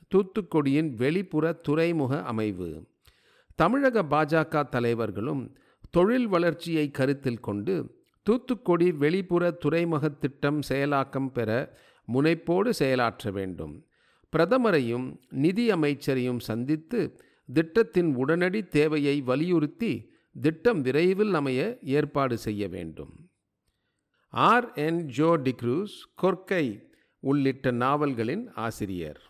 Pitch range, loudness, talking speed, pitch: 125-170 Hz, -26 LUFS, 85 wpm, 145 Hz